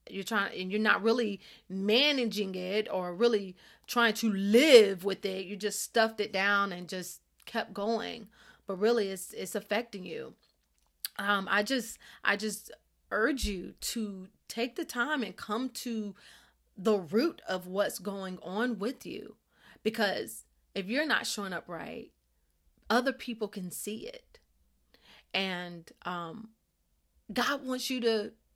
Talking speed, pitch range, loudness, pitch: 145 wpm, 190-230 Hz, -31 LUFS, 210 Hz